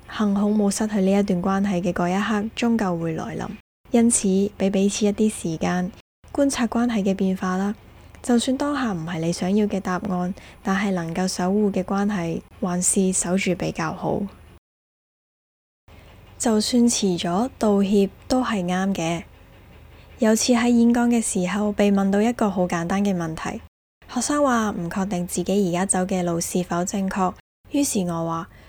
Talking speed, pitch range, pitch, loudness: 240 characters per minute, 180-215 Hz, 195 Hz, -22 LUFS